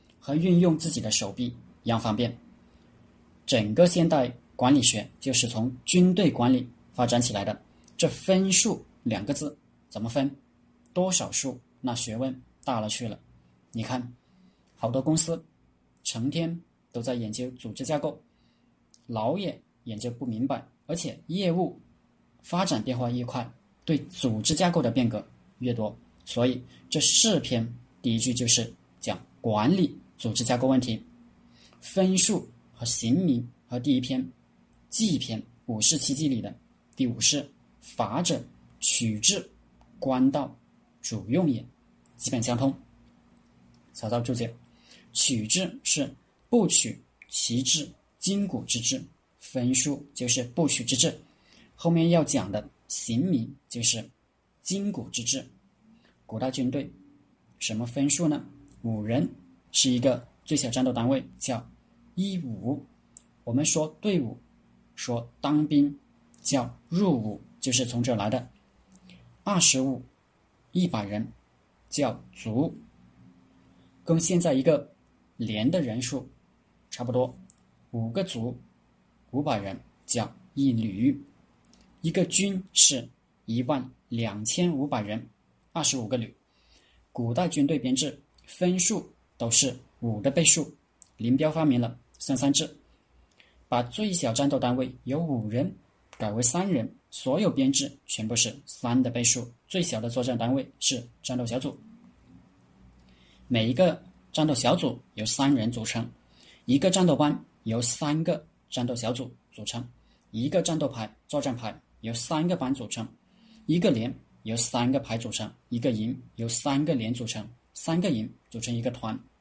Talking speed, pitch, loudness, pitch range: 195 characters per minute, 125 Hz, -25 LUFS, 115-150 Hz